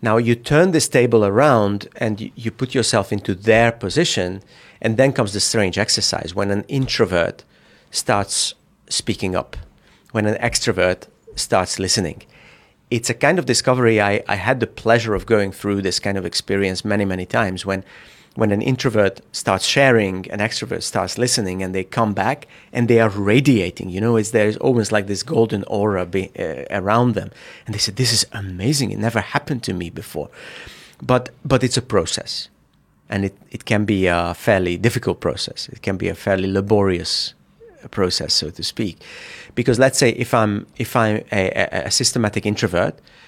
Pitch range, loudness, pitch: 95-120 Hz, -19 LUFS, 110 Hz